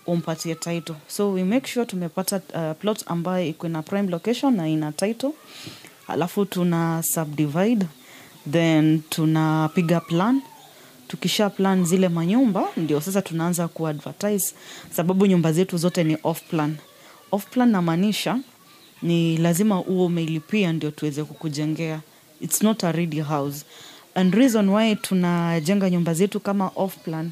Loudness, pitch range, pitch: -23 LUFS, 160-200 Hz, 175 Hz